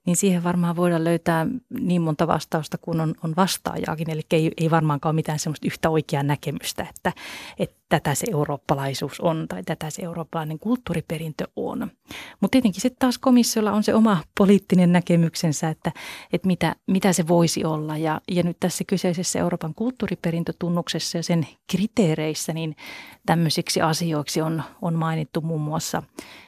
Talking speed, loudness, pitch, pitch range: 155 wpm, -23 LUFS, 170 Hz, 160-185 Hz